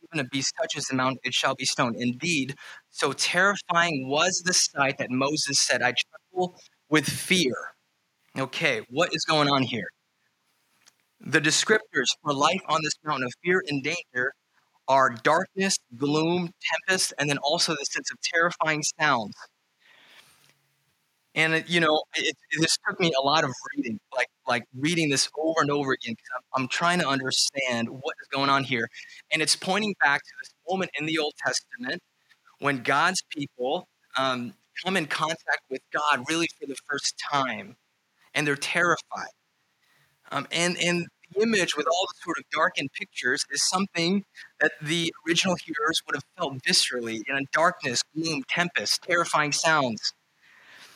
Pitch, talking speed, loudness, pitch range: 155 Hz, 165 wpm, -25 LUFS, 135-175 Hz